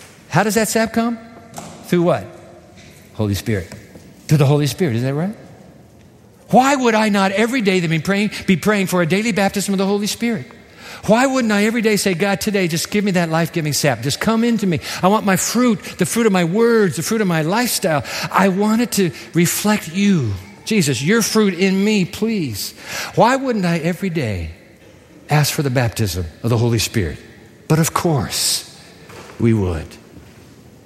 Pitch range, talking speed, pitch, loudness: 135-215 Hz, 185 wpm, 185 Hz, -17 LUFS